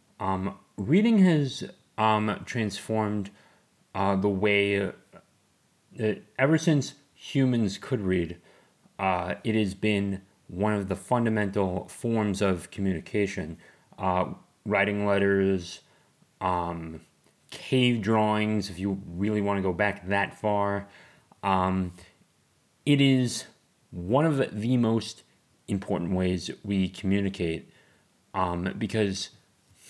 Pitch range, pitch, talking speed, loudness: 95-110 Hz, 100 Hz, 105 wpm, -27 LUFS